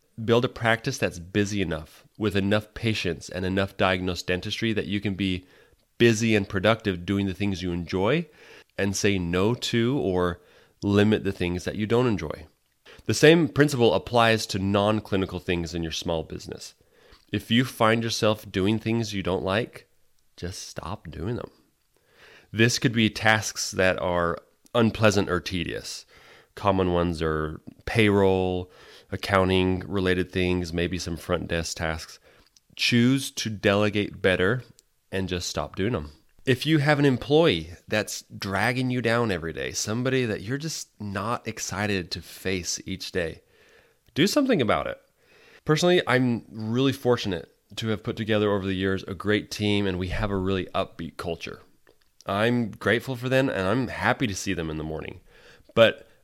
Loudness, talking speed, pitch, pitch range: -25 LUFS, 160 wpm, 100 Hz, 90-115 Hz